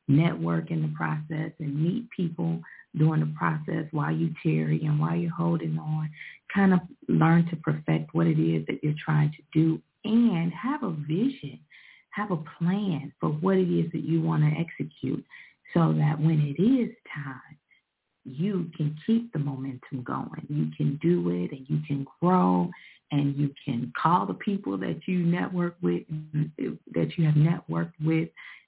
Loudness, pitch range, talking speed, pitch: -27 LUFS, 145-170 Hz, 170 wpm, 155 Hz